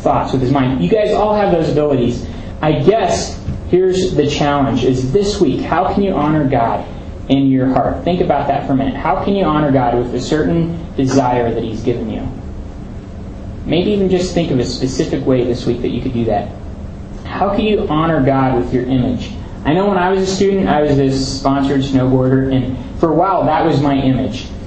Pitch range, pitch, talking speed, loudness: 120-155 Hz, 135 Hz, 215 wpm, -15 LUFS